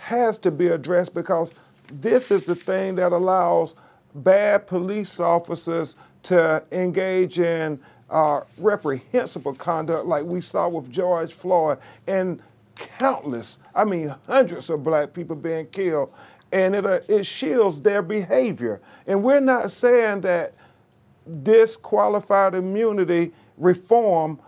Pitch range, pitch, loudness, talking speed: 165-200 Hz, 180 Hz, -22 LUFS, 125 wpm